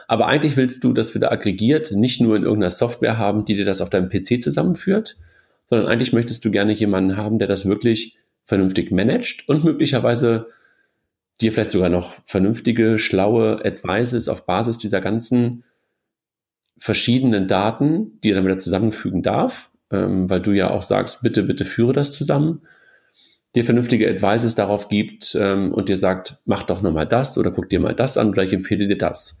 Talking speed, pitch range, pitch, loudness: 175 wpm, 100-120 Hz, 110 Hz, -19 LUFS